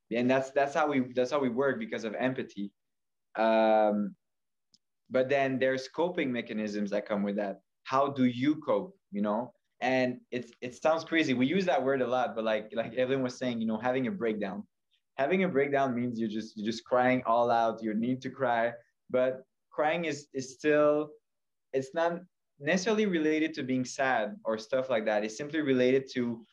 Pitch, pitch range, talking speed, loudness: 130 Hz, 115-140 Hz, 190 wpm, -30 LUFS